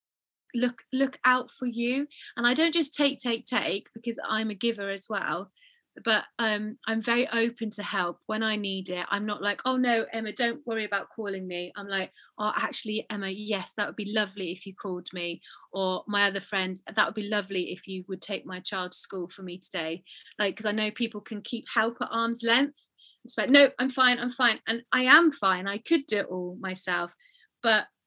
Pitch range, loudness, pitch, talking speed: 195-240 Hz, -28 LUFS, 215 Hz, 220 wpm